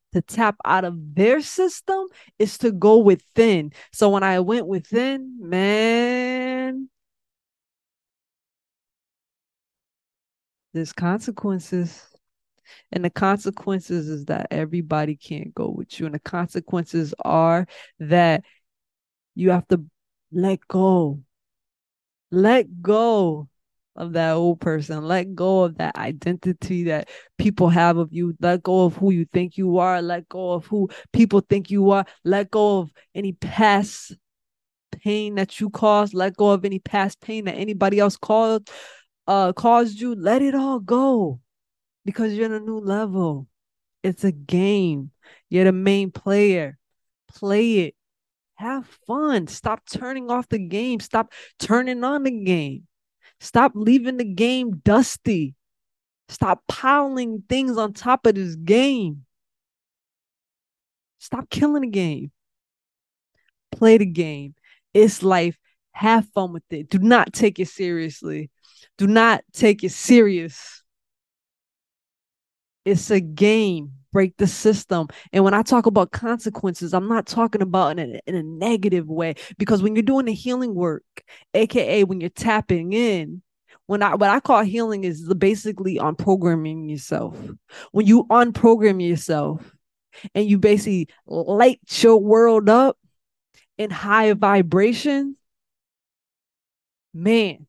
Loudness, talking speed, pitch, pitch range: -20 LUFS, 135 wpm, 195 Hz, 170-220 Hz